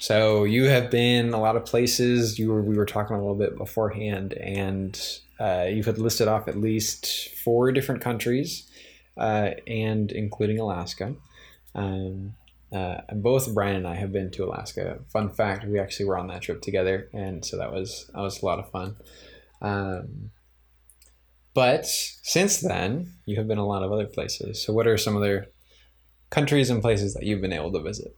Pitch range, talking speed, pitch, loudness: 95-115 Hz, 190 wpm, 105 Hz, -26 LUFS